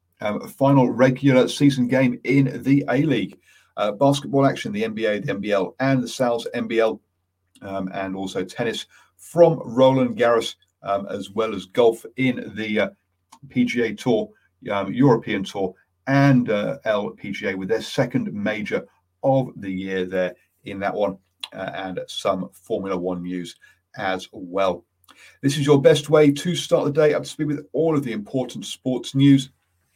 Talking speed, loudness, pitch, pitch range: 160 wpm, -22 LUFS, 125 Hz, 95-140 Hz